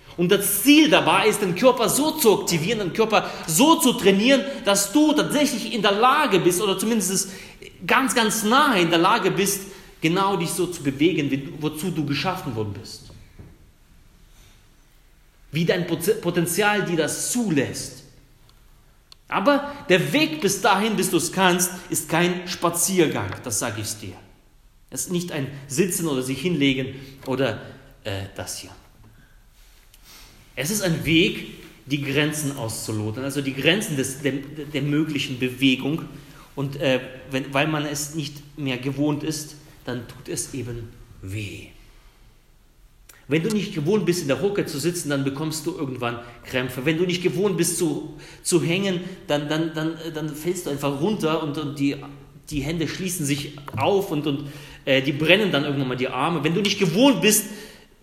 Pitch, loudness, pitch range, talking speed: 155 Hz, -22 LUFS, 135-185 Hz, 165 wpm